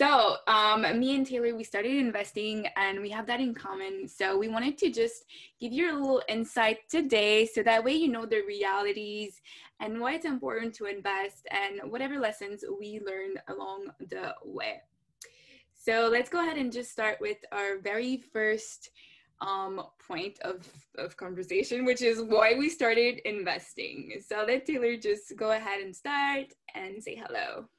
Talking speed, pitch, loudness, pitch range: 170 wpm, 225 Hz, -30 LUFS, 205-260 Hz